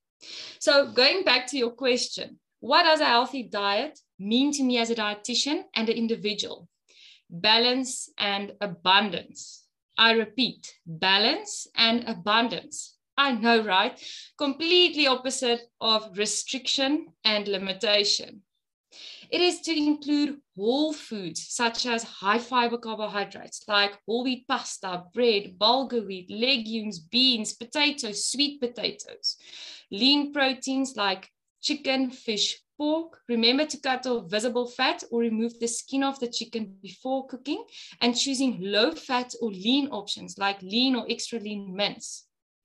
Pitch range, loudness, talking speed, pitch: 210-270 Hz, -25 LUFS, 130 wpm, 235 Hz